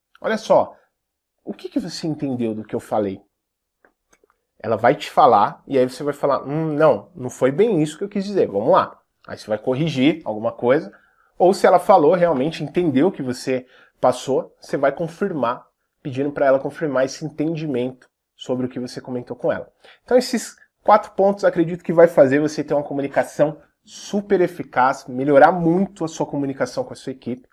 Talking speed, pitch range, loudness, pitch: 190 wpm, 130-170 Hz, -20 LUFS, 145 Hz